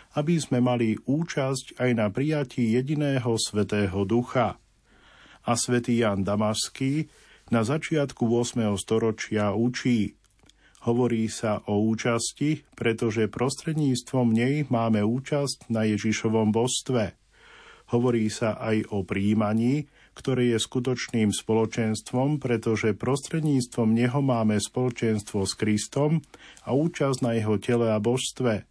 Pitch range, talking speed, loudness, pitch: 110-130 Hz, 115 wpm, -26 LUFS, 120 Hz